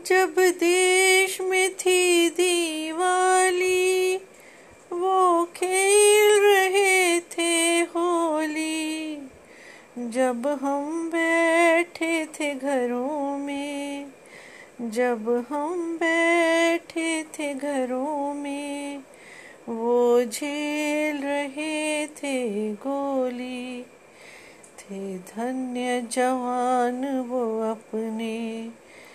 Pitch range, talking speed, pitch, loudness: 255-360 Hz, 65 wpm, 305 Hz, -23 LUFS